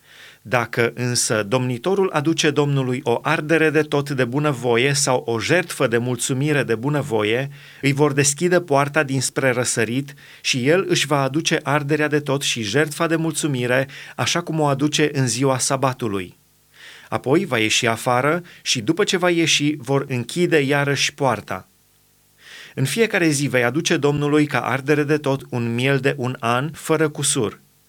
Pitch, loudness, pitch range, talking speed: 140 Hz, -20 LUFS, 125-155 Hz, 155 wpm